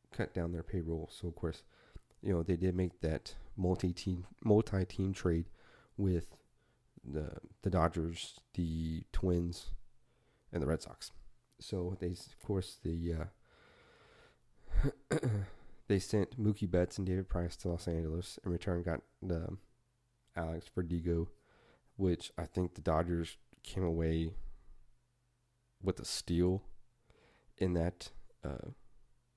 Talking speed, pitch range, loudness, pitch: 125 wpm, 85-100 Hz, -38 LUFS, 90 Hz